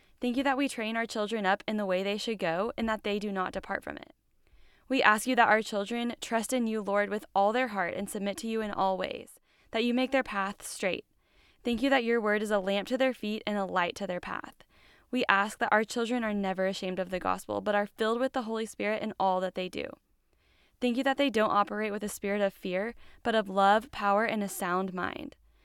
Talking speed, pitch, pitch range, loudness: 255 wpm, 210 Hz, 195-235 Hz, -30 LUFS